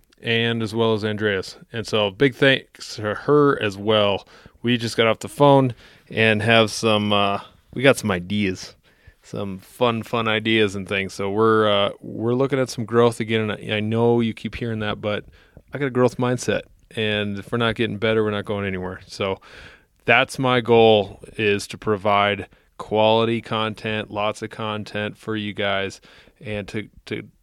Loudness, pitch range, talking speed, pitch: -21 LUFS, 105-115 Hz, 180 wpm, 110 Hz